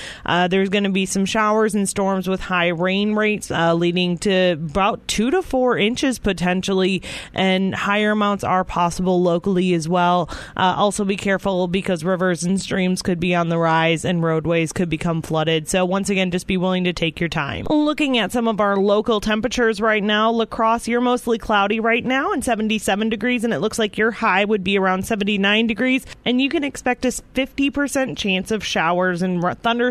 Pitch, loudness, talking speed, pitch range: 195 Hz, -19 LUFS, 195 wpm, 180-225 Hz